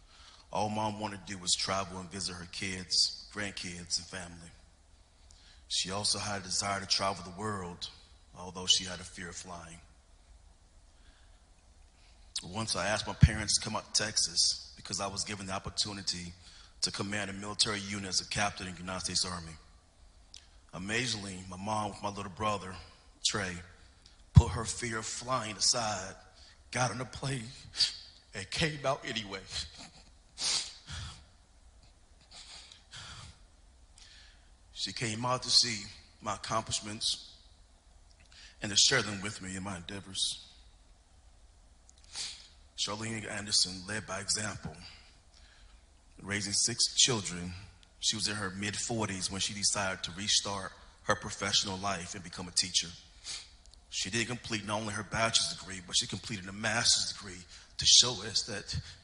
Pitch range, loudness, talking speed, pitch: 85-105 Hz, -31 LUFS, 145 wpm, 95 Hz